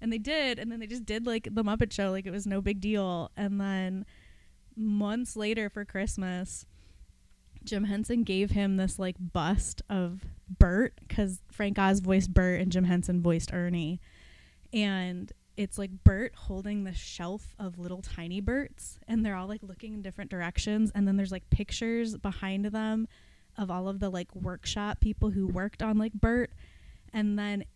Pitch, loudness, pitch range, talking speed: 195 Hz, -31 LUFS, 185-215 Hz, 180 wpm